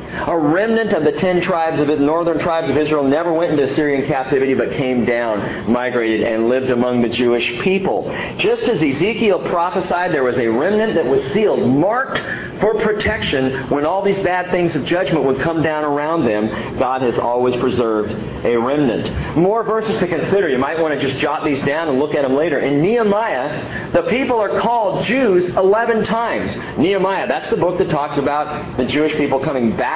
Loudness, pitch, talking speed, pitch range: -17 LUFS, 155 Hz, 195 wpm, 130-190 Hz